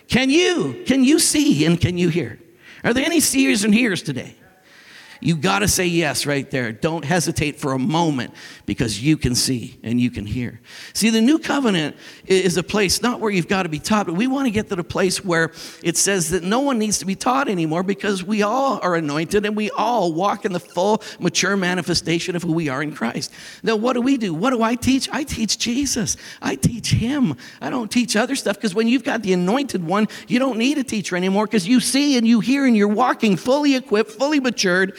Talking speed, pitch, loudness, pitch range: 230 wpm, 205 Hz, -19 LUFS, 170-245 Hz